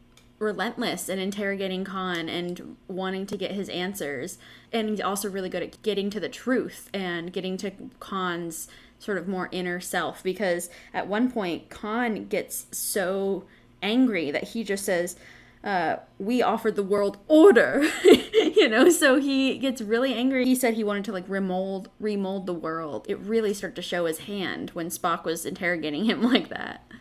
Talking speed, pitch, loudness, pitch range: 175 wpm, 195 Hz, -26 LUFS, 180-230 Hz